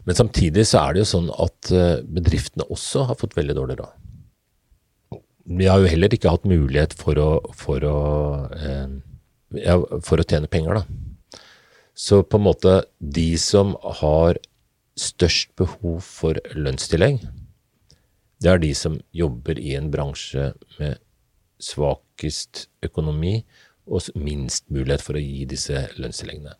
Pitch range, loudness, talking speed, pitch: 75-95 Hz, -21 LUFS, 140 wpm, 85 Hz